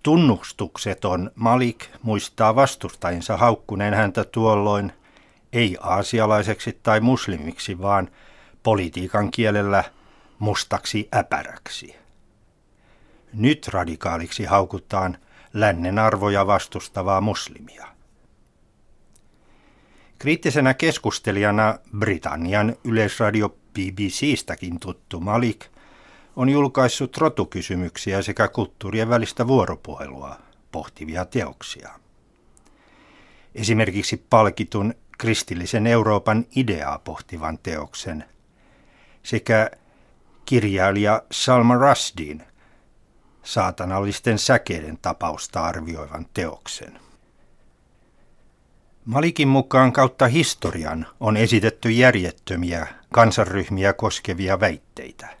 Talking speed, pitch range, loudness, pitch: 70 wpm, 90-115 Hz, -21 LUFS, 105 Hz